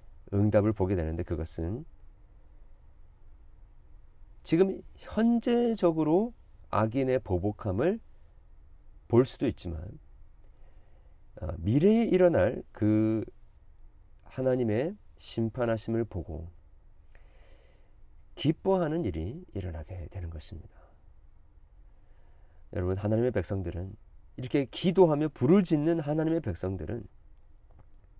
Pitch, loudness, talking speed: 100 Hz, -29 LUFS, 200 characters per minute